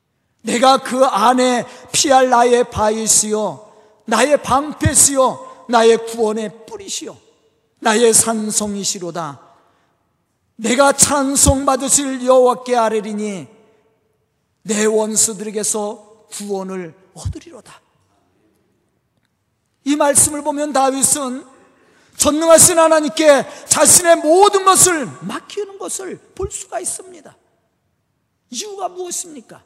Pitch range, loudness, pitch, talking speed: 215-300 Hz, -14 LUFS, 250 Hz, 225 characters per minute